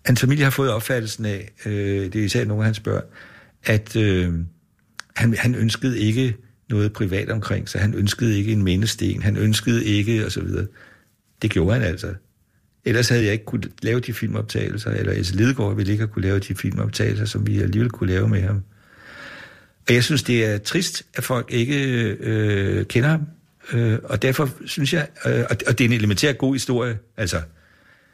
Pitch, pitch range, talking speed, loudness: 110 Hz, 105-120 Hz, 190 wpm, -21 LUFS